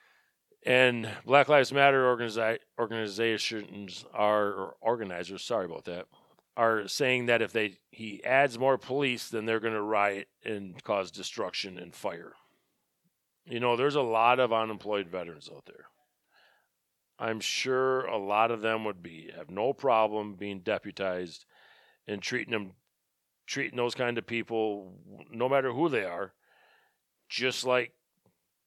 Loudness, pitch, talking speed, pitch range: -29 LUFS, 115 Hz, 145 wpm, 105-125 Hz